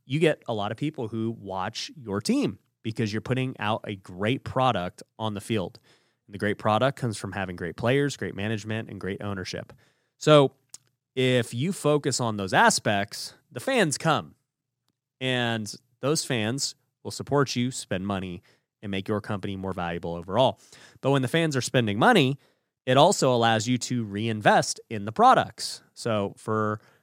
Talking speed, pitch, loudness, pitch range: 170 wpm, 115 Hz, -26 LUFS, 105-130 Hz